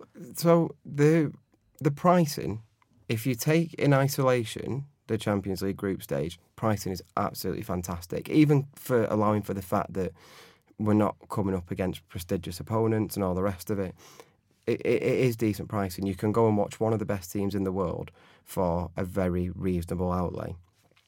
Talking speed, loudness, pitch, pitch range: 175 wpm, -28 LUFS, 105 Hz, 95-120 Hz